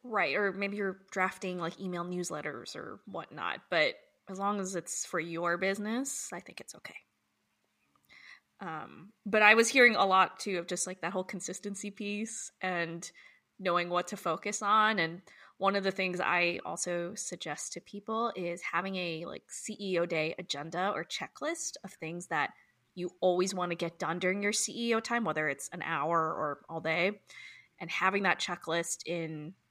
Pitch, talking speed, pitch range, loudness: 185 Hz, 175 wpm, 170-205 Hz, -32 LUFS